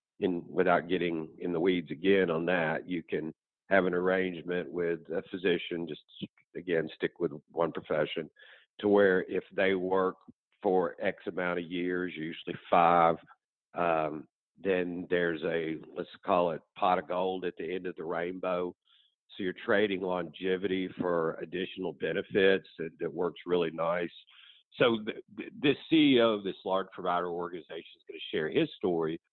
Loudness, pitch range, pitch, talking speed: -31 LUFS, 85-95 Hz, 90 Hz, 155 wpm